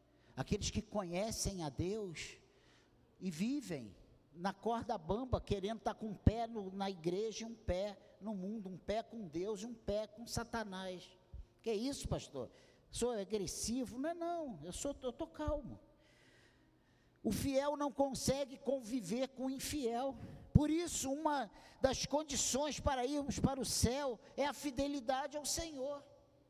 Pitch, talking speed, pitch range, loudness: 235 Hz, 160 wpm, 205-275 Hz, -40 LUFS